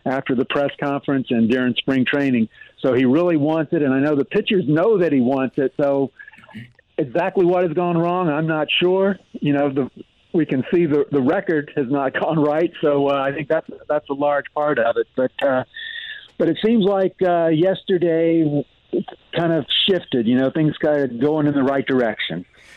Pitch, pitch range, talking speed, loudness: 150 Hz, 135-175 Hz, 205 wpm, -19 LUFS